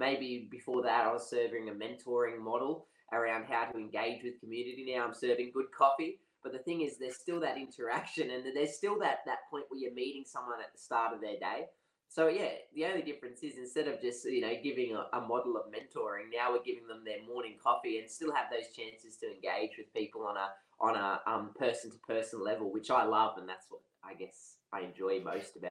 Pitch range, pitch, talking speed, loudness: 120-190 Hz, 130 Hz, 225 wpm, -36 LUFS